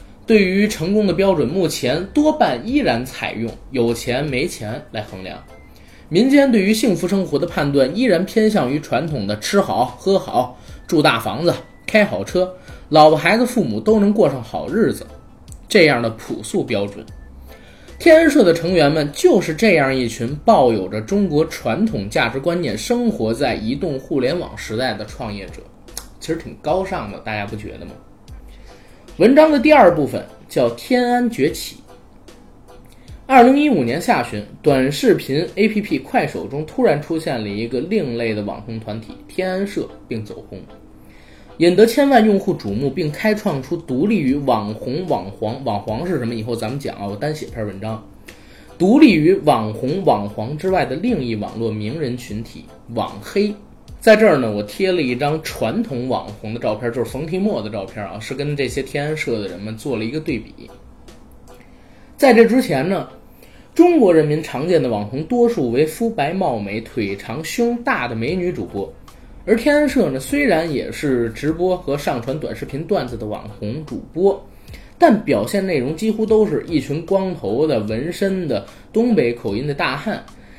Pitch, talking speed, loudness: 155 Hz, 255 characters per minute, -18 LUFS